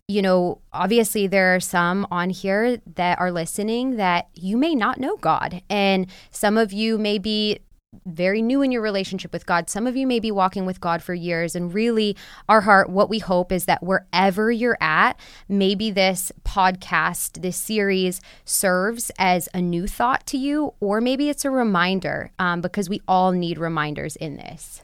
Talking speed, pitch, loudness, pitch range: 185 wpm, 195 Hz, -21 LUFS, 180-215 Hz